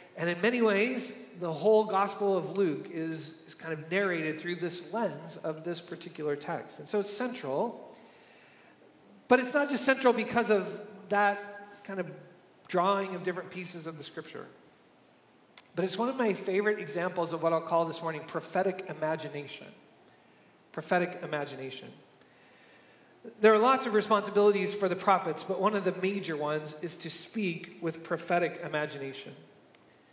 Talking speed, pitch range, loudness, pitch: 155 wpm, 165-205 Hz, -30 LUFS, 180 Hz